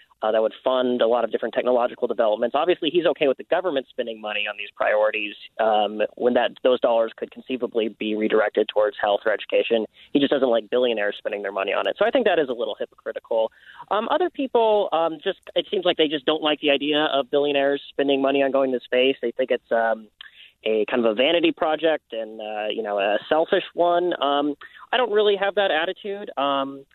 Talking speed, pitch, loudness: 220 wpm, 140 Hz, -22 LUFS